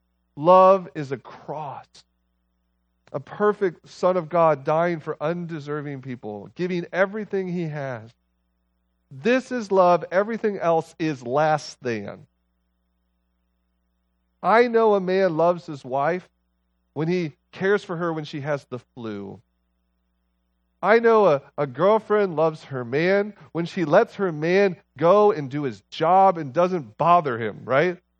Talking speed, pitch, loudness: 140 wpm, 155 Hz, -22 LUFS